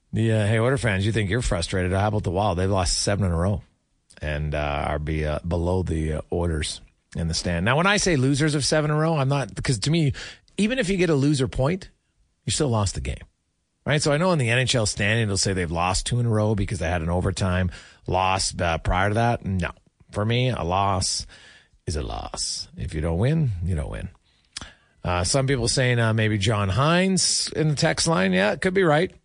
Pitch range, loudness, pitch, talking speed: 90-135 Hz, -23 LUFS, 105 Hz, 230 wpm